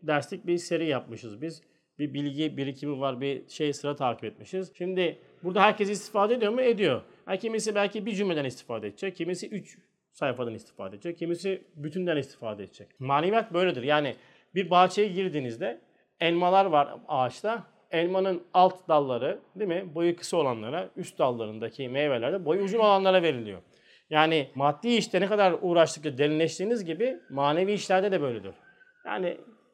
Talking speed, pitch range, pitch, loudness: 145 wpm, 145-195 Hz, 170 Hz, -27 LUFS